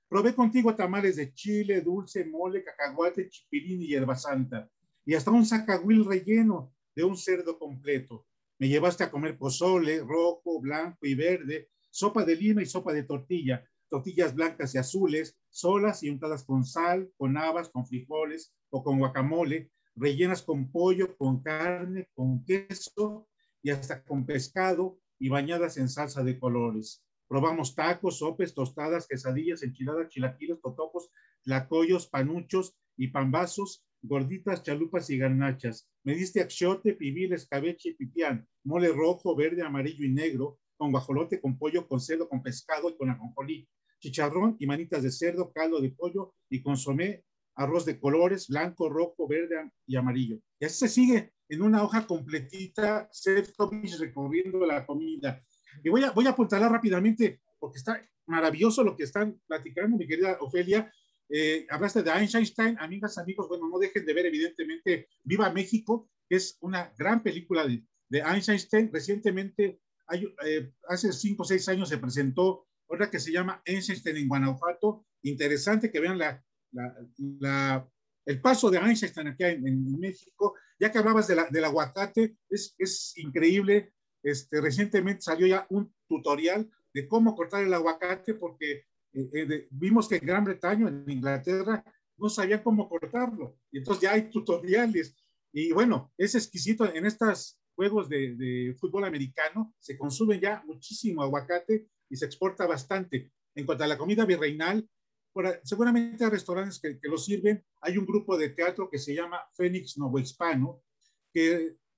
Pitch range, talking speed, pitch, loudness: 145-200 Hz, 160 wpm, 170 Hz, -29 LUFS